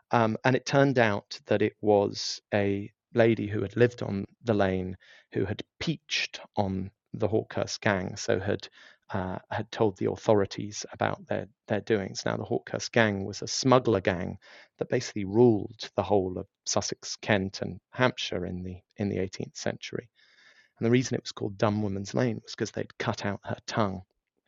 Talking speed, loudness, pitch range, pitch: 180 wpm, -29 LUFS, 100-115 Hz, 105 Hz